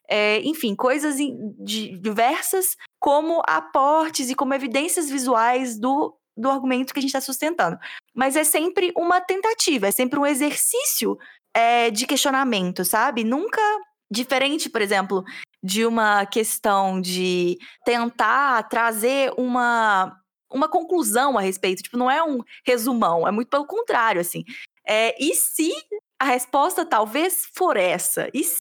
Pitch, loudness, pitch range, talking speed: 265 Hz, -21 LUFS, 225-310 Hz, 140 wpm